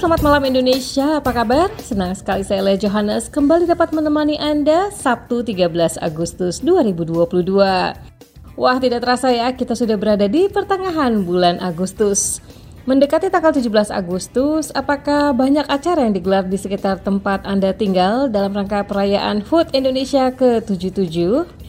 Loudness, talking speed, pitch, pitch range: -17 LUFS, 135 wpm, 240 Hz, 195-290 Hz